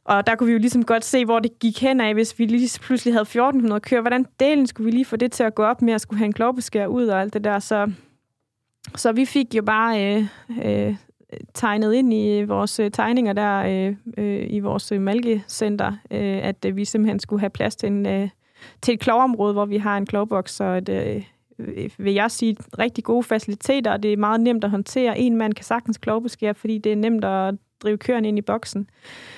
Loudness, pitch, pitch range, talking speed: -21 LUFS, 215 Hz, 205-235 Hz, 225 wpm